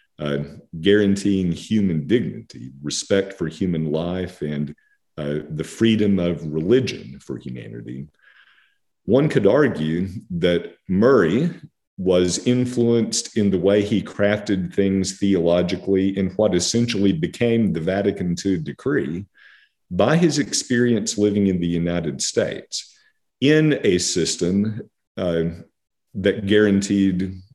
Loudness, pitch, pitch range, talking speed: -20 LUFS, 95 Hz, 85-105 Hz, 115 wpm